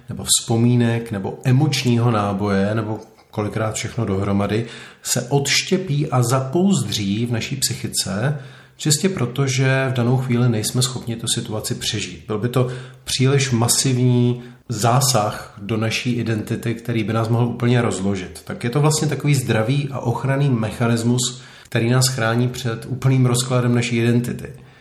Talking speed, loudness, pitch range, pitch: 145 wpm, -19 LUFS, 115-130 Hz, 120 Hz